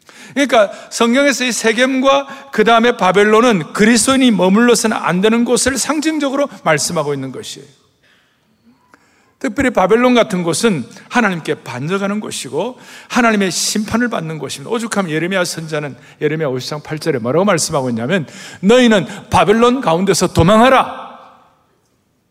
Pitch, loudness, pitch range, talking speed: 215 Hz, -14 LUFS, 165-245 Hz, 340 characters per minute